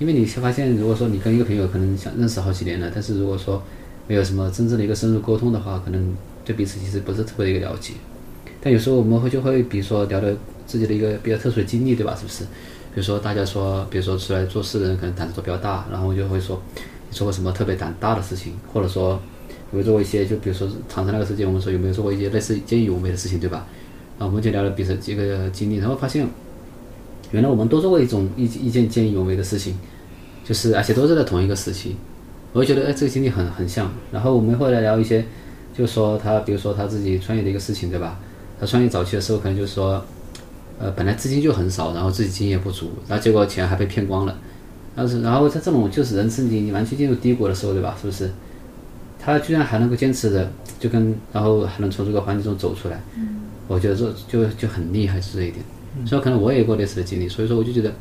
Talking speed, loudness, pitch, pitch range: 395 characters per minute, -21 LUFS, 105 Hz, 95-115 Hz